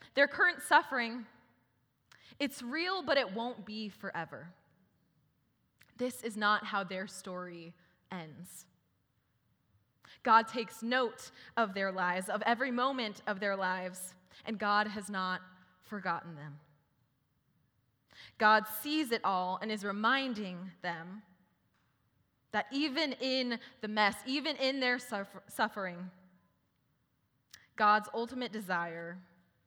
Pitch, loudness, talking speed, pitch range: 200 Hz, -33 LUFS, 110 wpm, 175-235 Hz